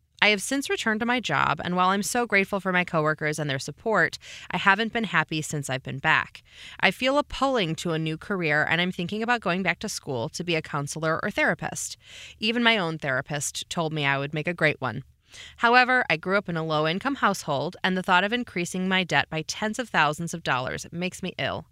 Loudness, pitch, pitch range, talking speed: -25 LUFS, 175 Hz, 155-205 Hz, 235 wpm